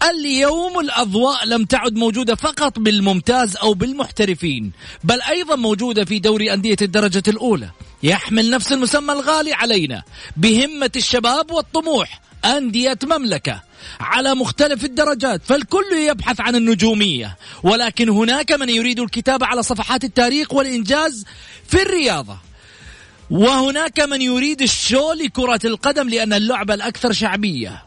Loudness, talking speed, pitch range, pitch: -17 LUFS, 120 wpm, 215-280 Hz, 245 Hz